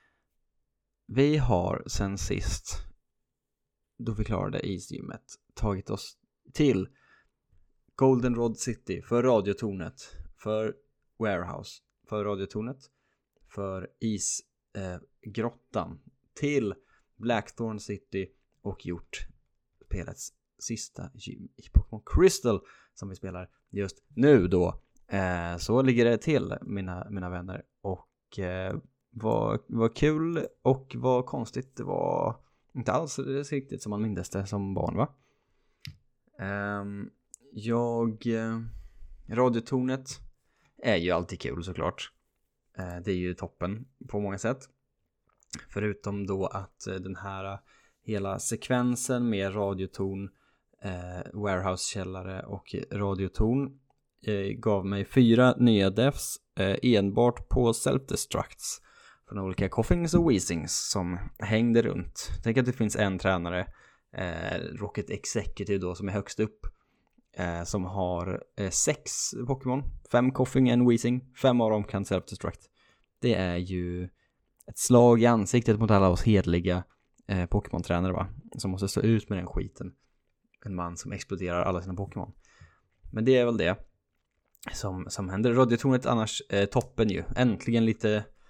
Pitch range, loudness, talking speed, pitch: 95-120 Hz, -29 LUFS, 125 wpm, 105 Hz